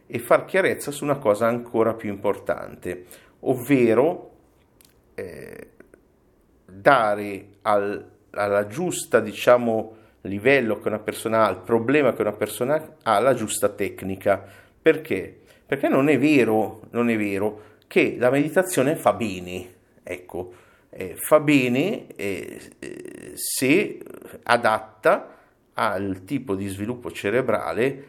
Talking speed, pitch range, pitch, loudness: 120 wpm, 100-130 Hz, 110 Hz, -22 LUFS